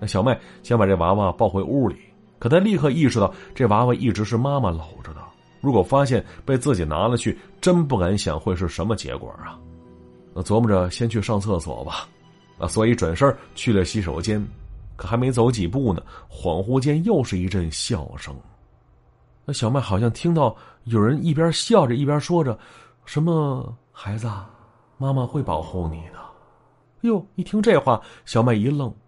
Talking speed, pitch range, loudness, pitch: 260 characters per minute, 95-135 Hz, -22 LUFS, 115 Hz